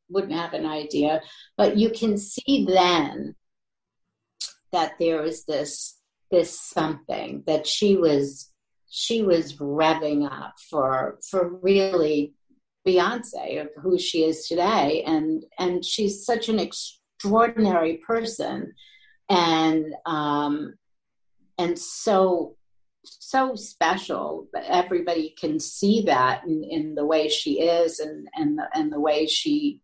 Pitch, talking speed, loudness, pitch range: 170 Hz, 125 wpm, -24 LUFS, 155-205 Hz